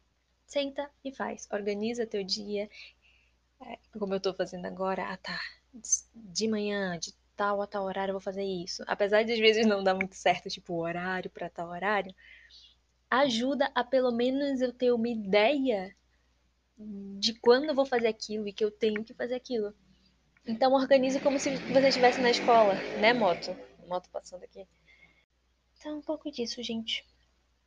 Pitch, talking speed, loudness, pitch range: 210 Hz, 165 wpm, -29 LUFS, 190-245 Hz